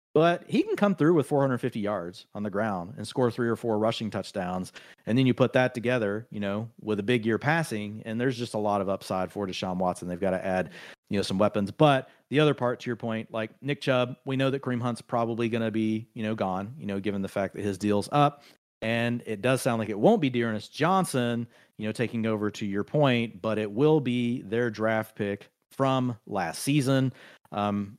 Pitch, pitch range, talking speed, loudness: 115 Hz, 105-130 Hz, 230 wpm, -28 LUFS